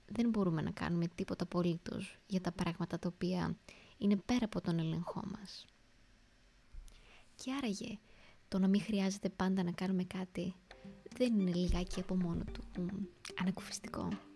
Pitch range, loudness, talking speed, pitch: 175-200 Hz, -38 LUFS, 140 wpm, 185 Hz